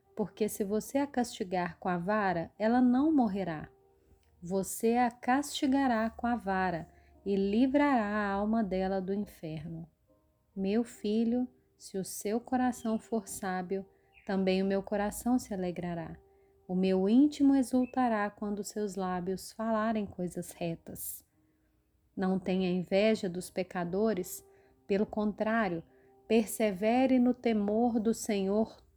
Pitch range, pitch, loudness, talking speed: 185-230 Hz, 210 Hz, -31 LUFS, 125 wpm